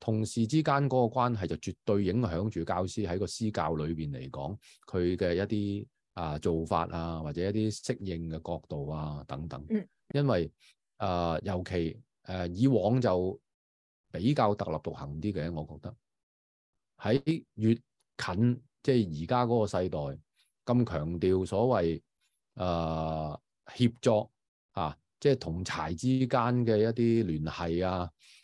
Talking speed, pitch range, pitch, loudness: 215 characters per minute, 80-120 Hz, 95 Hz, -31 LUFS